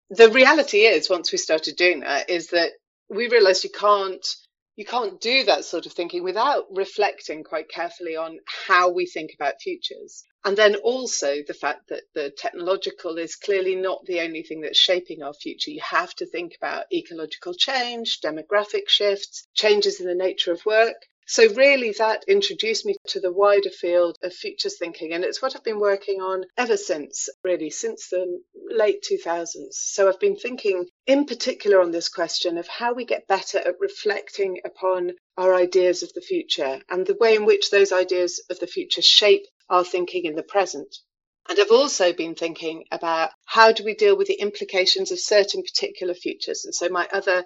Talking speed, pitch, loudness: 190 wpm, 200 Hz, -21 LUFS